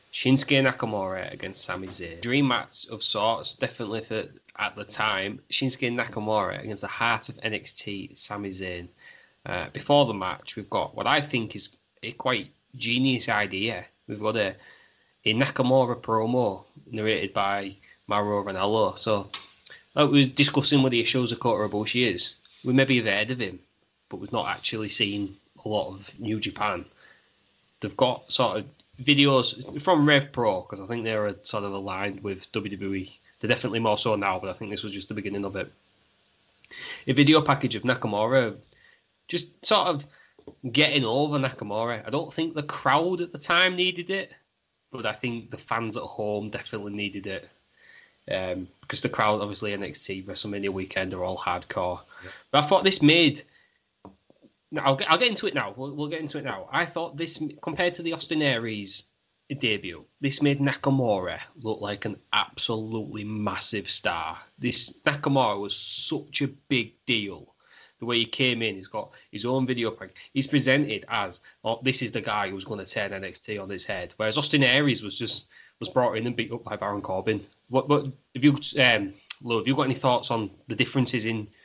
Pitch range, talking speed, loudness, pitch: 105-140 Hz, 185 wpm, -26 LUFS, 115 Hz